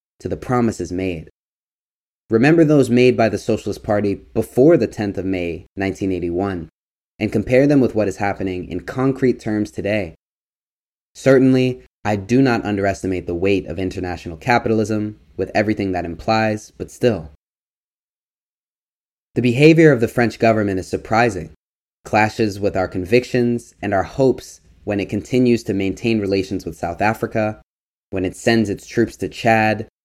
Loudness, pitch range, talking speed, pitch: -18 LUFS, 95-120 Hz, 150 wpm, 105 Hz